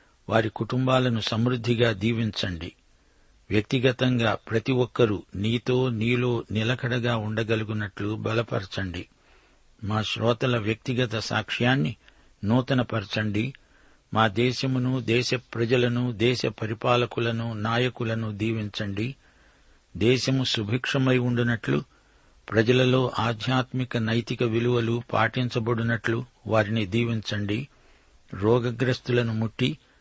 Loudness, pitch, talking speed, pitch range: -25 LUFS, 115 Hz, 75 wpm, 110-125 Hz